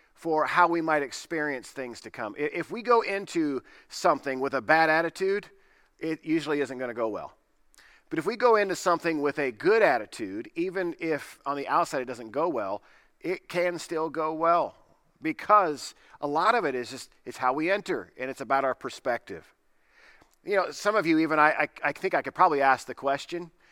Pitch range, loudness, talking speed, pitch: 140-190 Hz, -27 LUFS, 195 wpm, 160 Hz